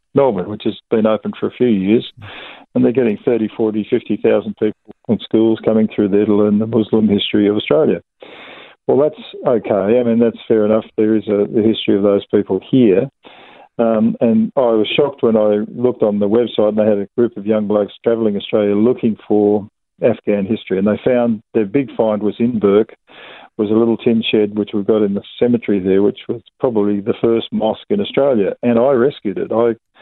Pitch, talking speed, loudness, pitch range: 110 Hz, 210 wpm, -16 LUFS, 105-115 Hz